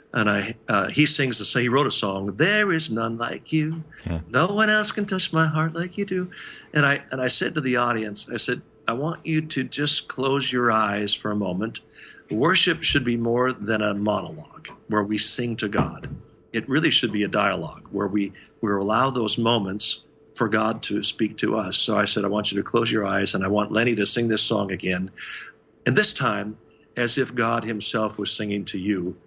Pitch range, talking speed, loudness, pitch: 105-135 Hz, 215 wpm, -22 LUFS, 115 Hz